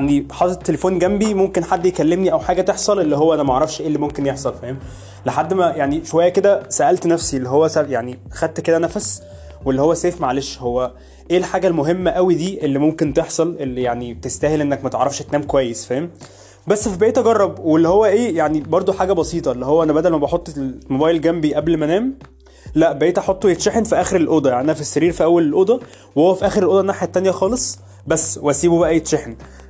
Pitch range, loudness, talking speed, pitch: 135-180 Hz, -17 LUFS, 205 wpm, 160 Hz